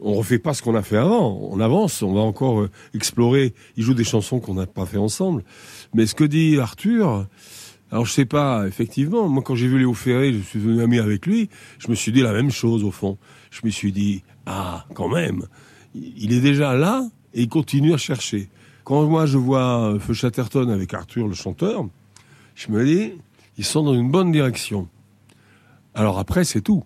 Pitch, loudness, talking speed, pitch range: 120 Hz, -20 LUFS, 210 wpm, 105-140 Hz